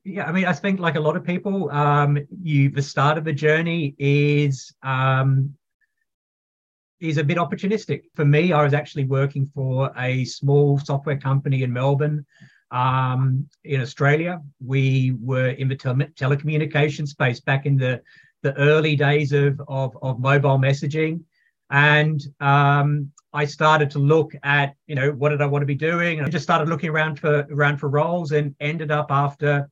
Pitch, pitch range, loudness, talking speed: 145 Hz, 140-155 Hz, -21 LUFS, 175 wpm